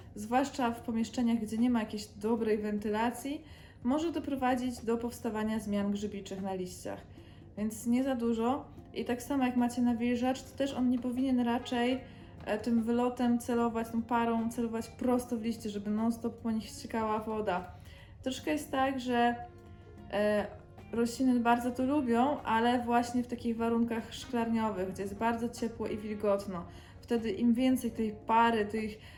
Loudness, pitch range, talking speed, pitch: -32 LUFS, 215-245 Hz, 150 wpm, 235 Hz